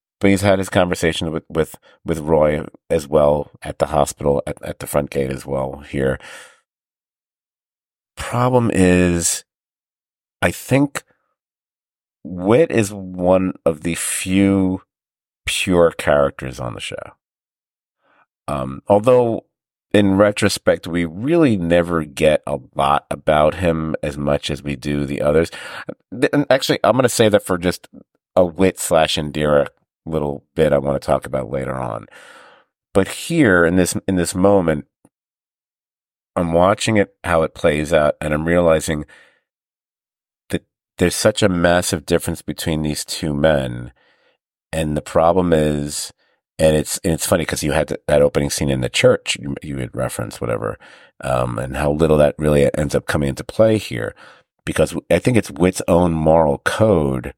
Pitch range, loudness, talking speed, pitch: 70-95 Hz, -18 LUFS, 155 wpm, 80 Hz